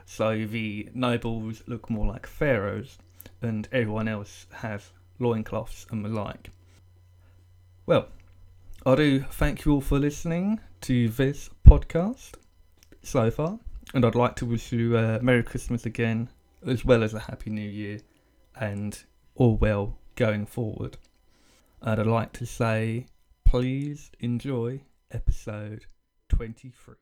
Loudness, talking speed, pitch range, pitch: -27 LUFS, 130 wpm, 100-125 Hz, 110 Hz